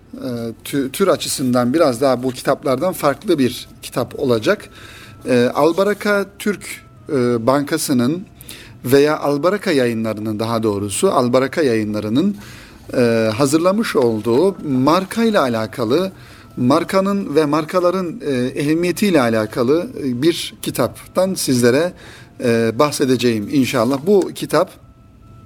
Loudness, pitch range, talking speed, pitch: -17 LUFS, 115-160 Hz, 85 wpm, 130 Hz